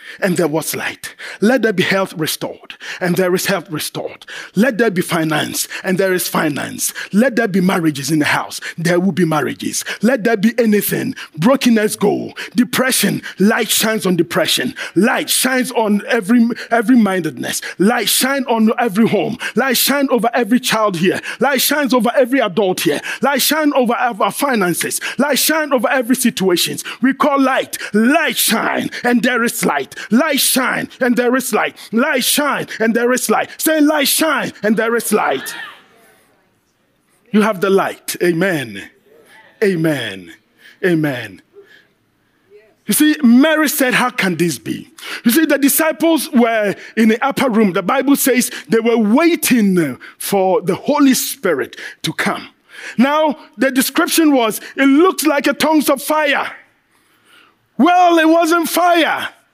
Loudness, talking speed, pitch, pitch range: -15 LUFS, 155 wpm, 235 Hz, 200-275 Hz